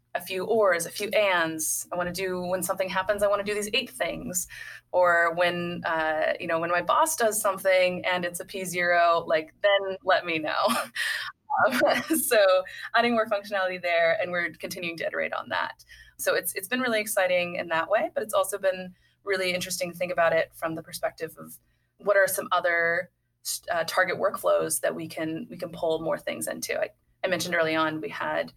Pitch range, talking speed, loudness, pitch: 170-200 Hz, 205 wpm, -26 LUFS, 180 Hz